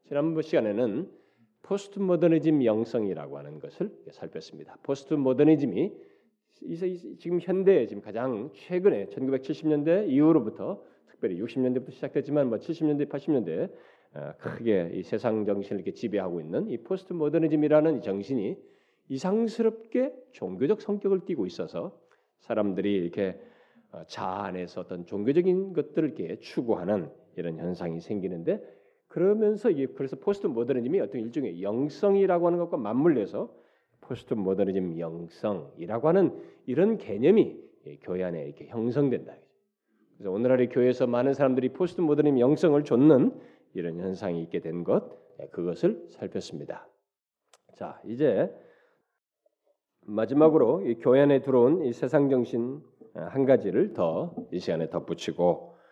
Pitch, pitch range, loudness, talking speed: 135 Hz, 100-165 Hz, -27 LUFS, 320 characters per minute